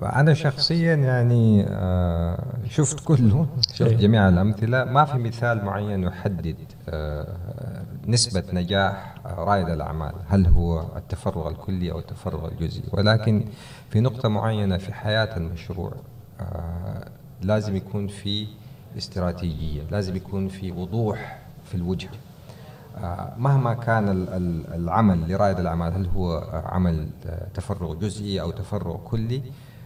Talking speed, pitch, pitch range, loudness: 110 wpm, 100 Hz, 90-120 Hz, -24 LUFS